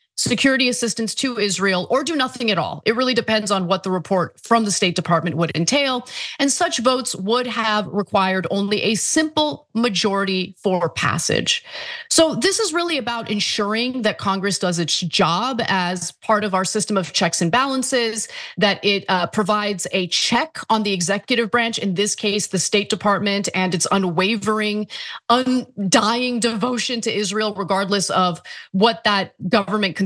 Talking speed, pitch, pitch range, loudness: 165 wpm, 210 Hz, 195-240 Hz, -19 LUFS